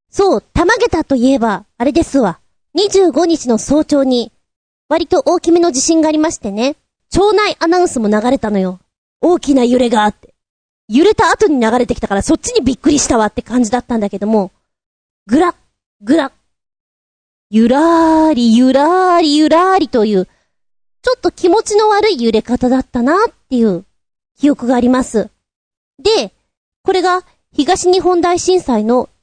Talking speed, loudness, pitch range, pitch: 310 characters per minute, -13 LUFS, 240-350 Hz, 290 Hz